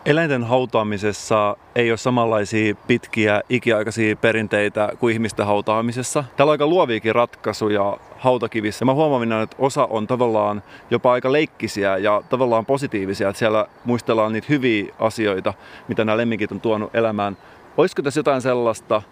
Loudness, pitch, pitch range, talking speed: -20 LUFS, 115 Hz, 105-125 Hz, 145 wpm